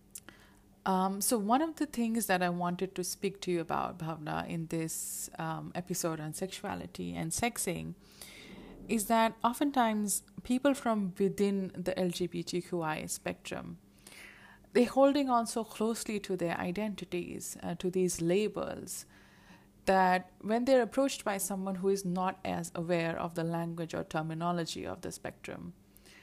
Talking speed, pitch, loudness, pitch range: 145 wpm, 185 Hz, -33 LUFS, 170-215 Hz